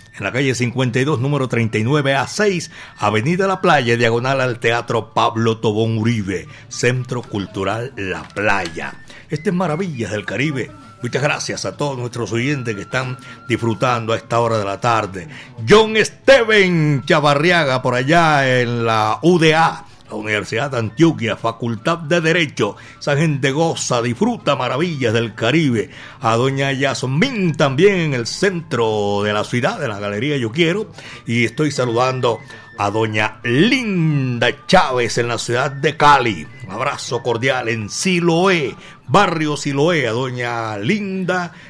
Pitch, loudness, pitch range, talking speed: 130 Hz, -17 LUFS, 115-160 Hz, 140 wpm